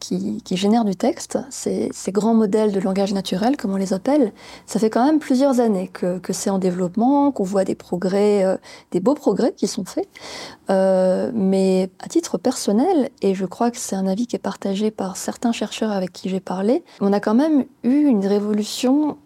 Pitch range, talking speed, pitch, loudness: 195-255 Hz, 210 wpm, 215 Hz, -20 LUFS